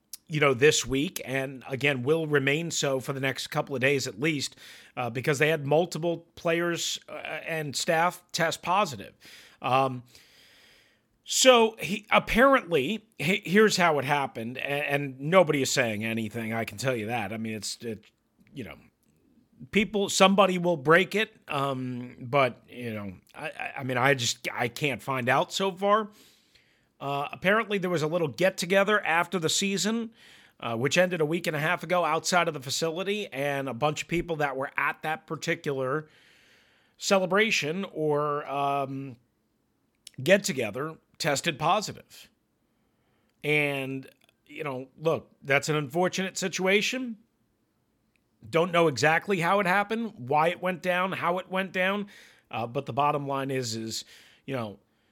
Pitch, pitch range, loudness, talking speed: 150 Hz, 135-180 Hz, -26 LUFS, 160 wpm